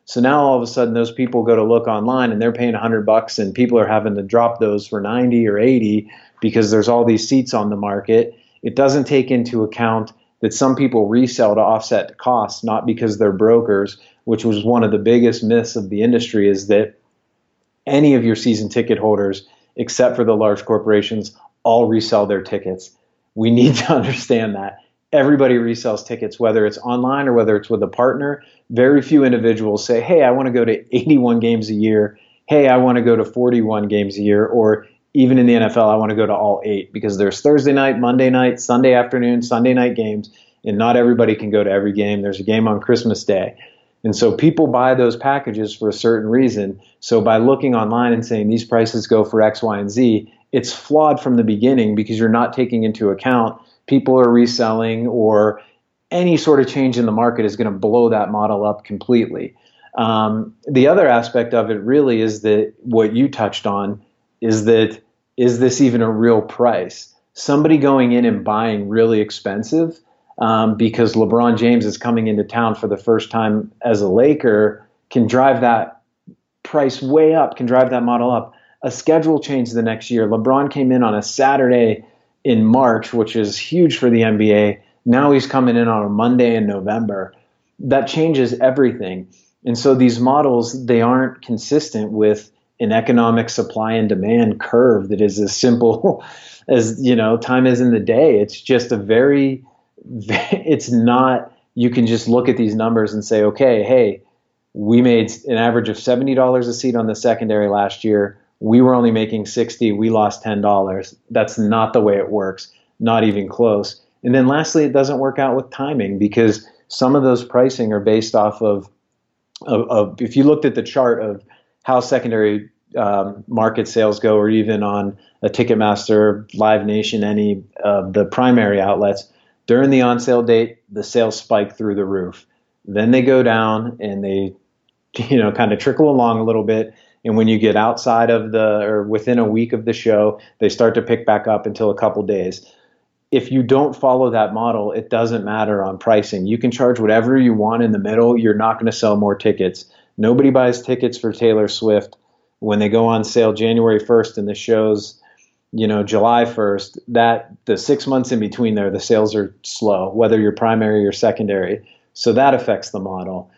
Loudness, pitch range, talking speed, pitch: -16 LUFS, 105-125 Hz, 195 wpm, 115 Hz